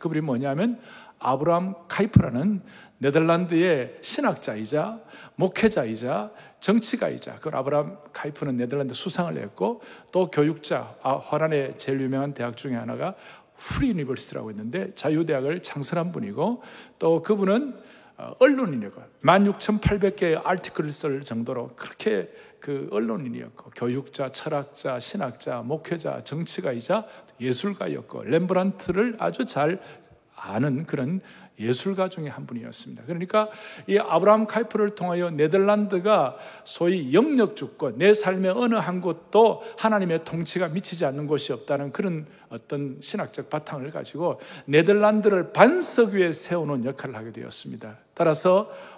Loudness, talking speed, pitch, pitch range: -25 LUFS, 320 characters per minute, 175 Hz, 145-205 Hz